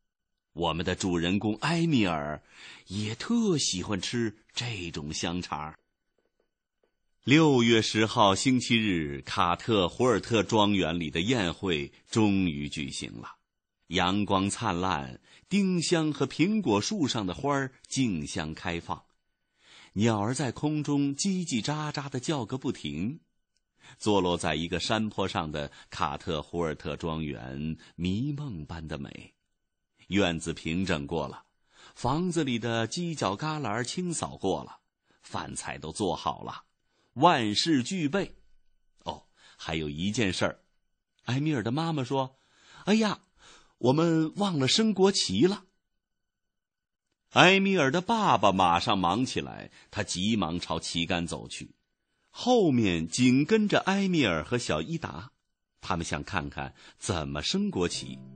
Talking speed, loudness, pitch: 190 characters per minute, -28 LUFS, 105 Hz